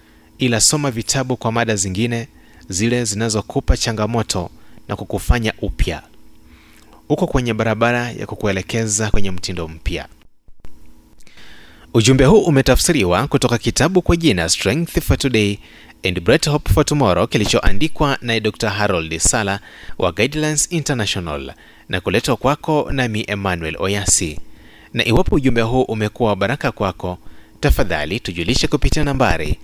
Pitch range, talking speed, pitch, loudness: 95-130 Hz, 120 wpm, 110 Hz, -18 LUFS